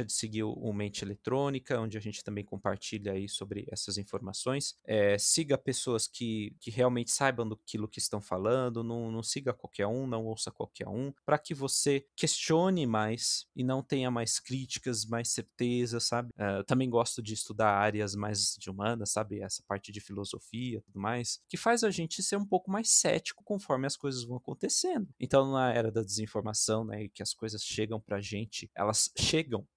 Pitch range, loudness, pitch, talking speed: 105-130 Hz, -32 LUFS, 115 Hz, 185 wpm